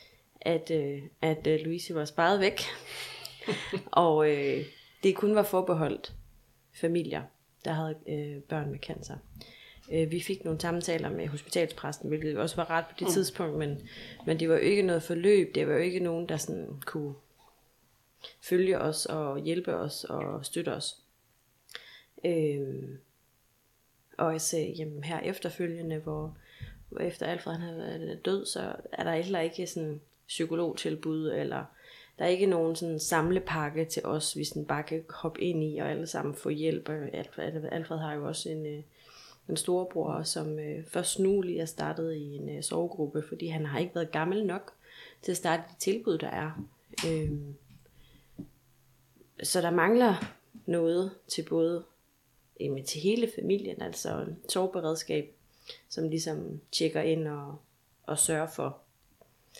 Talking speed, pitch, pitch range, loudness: 145 wpm, 160 Hz, 150-170 Hz, -31 LUFS